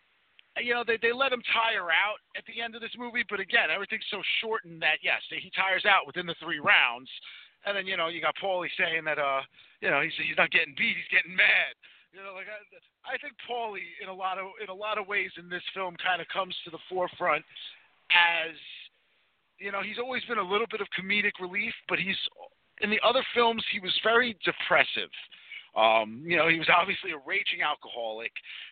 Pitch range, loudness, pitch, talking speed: 175-225 Hz, -27 LUFS, 195 Hz, 215 wpm